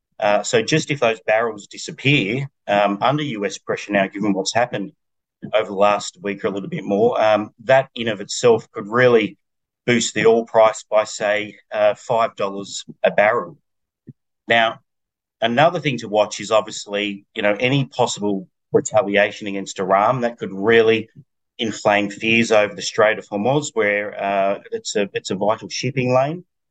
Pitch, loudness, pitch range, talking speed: 110 Hz, -19 LUFS, 100-125 Hz, 165 wpm